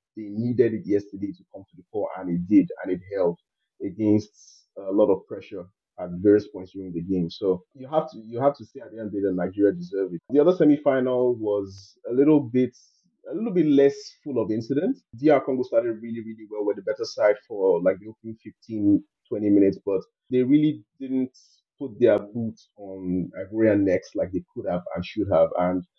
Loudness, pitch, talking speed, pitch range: -24 LUFS, 110 Hz, 215 wpm, 100-135 Hz